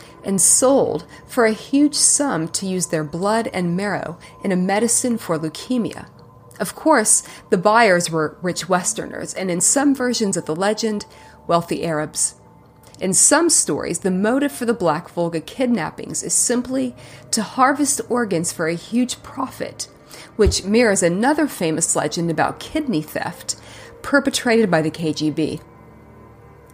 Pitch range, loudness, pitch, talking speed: 165-240 Hz, -19 LUFS, 195 Hz, 145 wpm